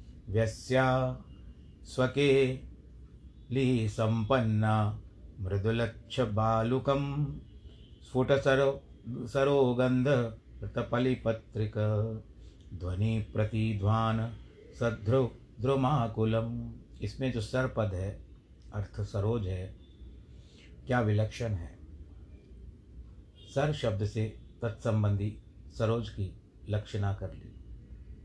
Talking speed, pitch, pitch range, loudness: 65 wpm, 110 Hz, 100-120 Hz, -31 LUFS